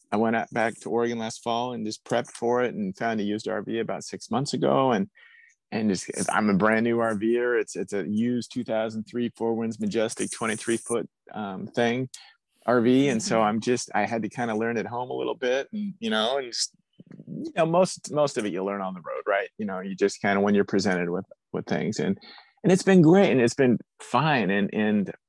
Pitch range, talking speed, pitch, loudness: 105-125 Hz, 235 wpm, 115 Hz, -26 LUFS